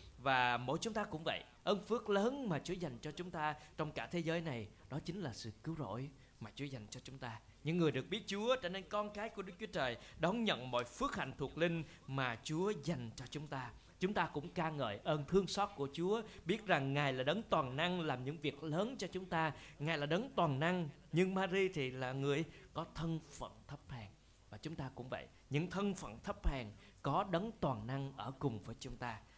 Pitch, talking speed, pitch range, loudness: 155 Hz, 235 wpm, 130-180 Hz, -40 LUFS